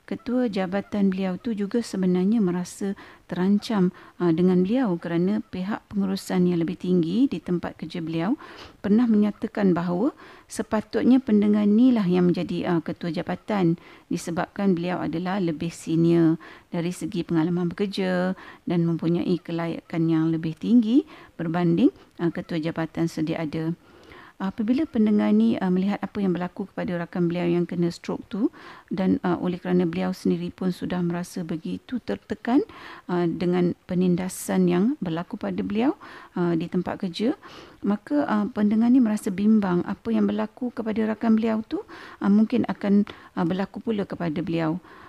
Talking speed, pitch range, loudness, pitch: 150 wpm, 175-225 Hz, -24 LUFS, 190 Hz